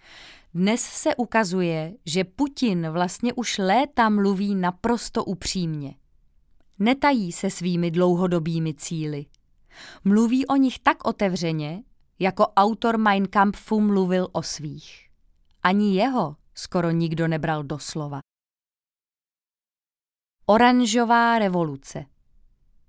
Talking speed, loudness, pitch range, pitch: 95 wpm, -22 LUFS, 155-220 Hz, 185 Hz